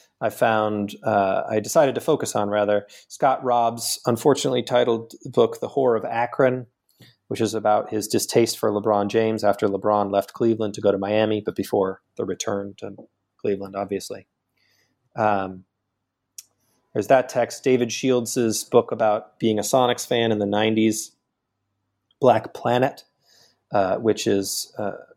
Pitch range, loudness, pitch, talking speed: 100-120 Hz, -22 LUFS, 110 Hz, 150 wpm